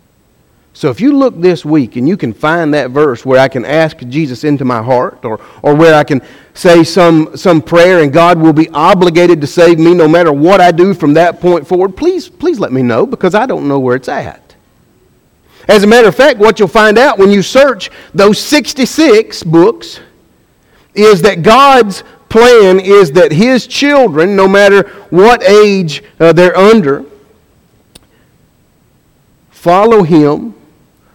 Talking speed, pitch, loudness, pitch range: 175 wpm, 180 Hz, -7 LUFS, 155-210 Hz